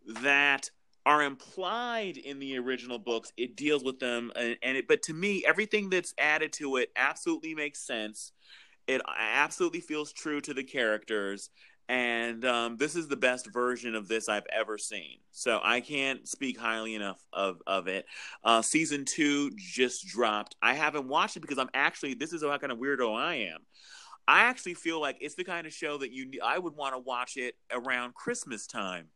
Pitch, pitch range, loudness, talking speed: 140 Hz, 120-160 Hz, -30 LUFS, 190 wpm